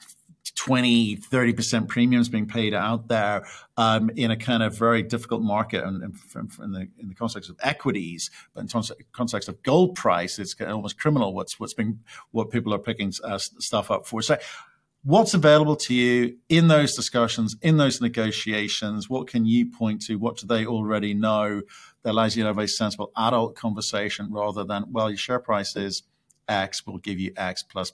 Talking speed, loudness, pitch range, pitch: 200 wpm, -24 LUFS, 105-120 Hz, 110 Hz